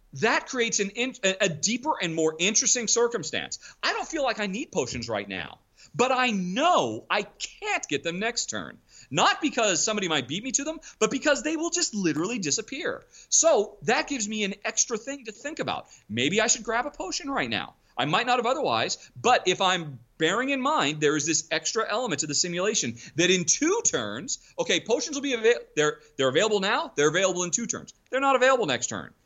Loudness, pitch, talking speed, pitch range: -25 LUFS, 225 Hz, 210 wpm, 180-275 Hz